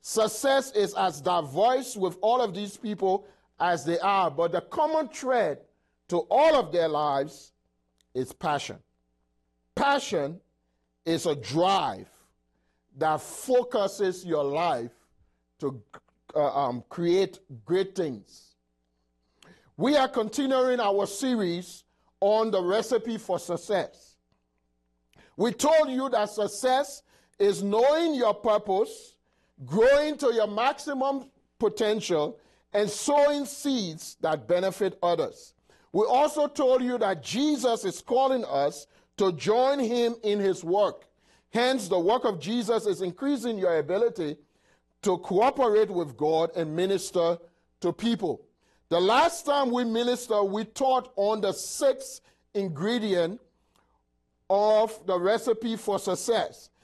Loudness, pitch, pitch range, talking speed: -26 LUFS, 200 Hz, 165-245 Hz, 120 wpm